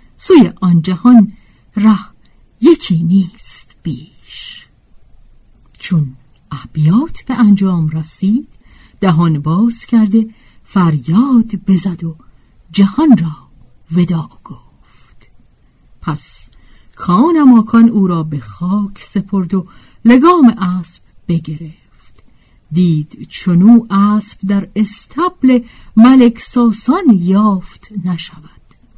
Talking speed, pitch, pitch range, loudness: 90 wpm, 190 Hz, 165-225 Hz, -12 LUFS